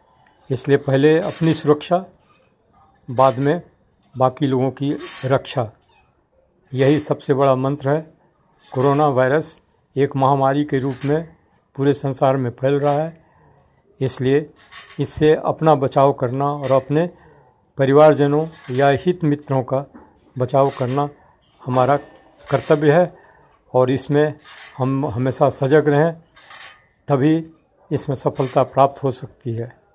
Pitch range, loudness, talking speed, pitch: 135-150 Hz, -18 LUFS, 115 wpm, 140 Hz